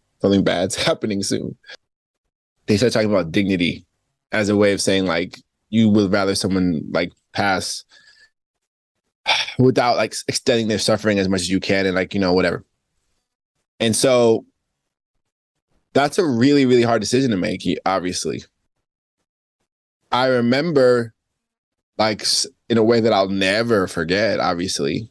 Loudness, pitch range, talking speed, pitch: -19 LUFS, 95-120 Hz, 140 wpm, 105 Hz